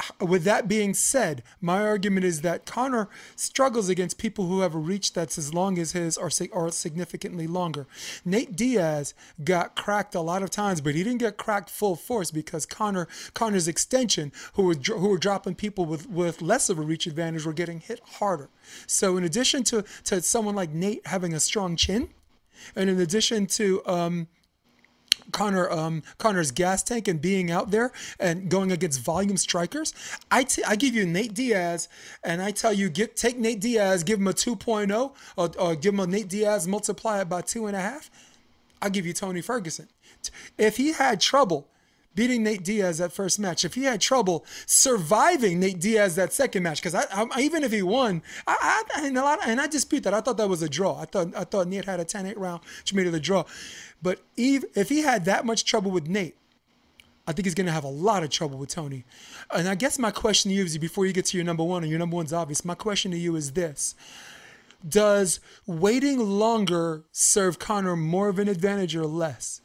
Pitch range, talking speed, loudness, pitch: 175-215 Hz, 210 wpm, -25 LUFS, 190 Hz